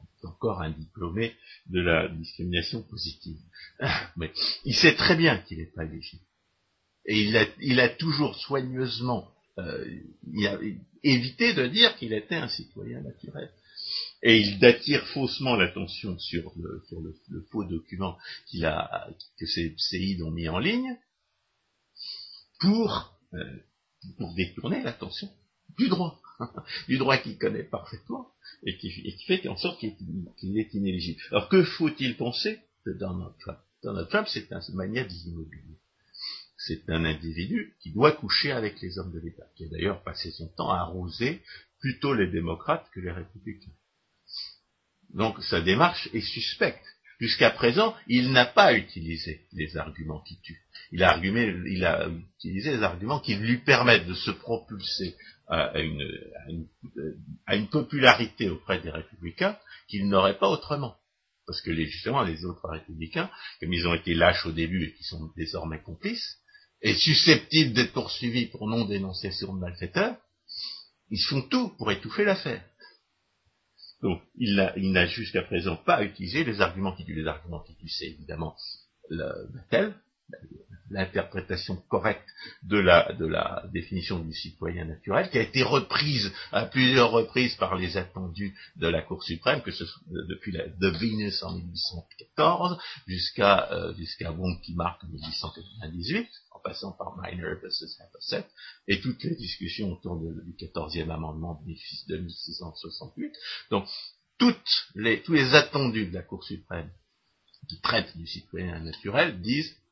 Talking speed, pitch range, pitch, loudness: 155 wpm, 85-125 Hz, 95 Hz, -27 LUFS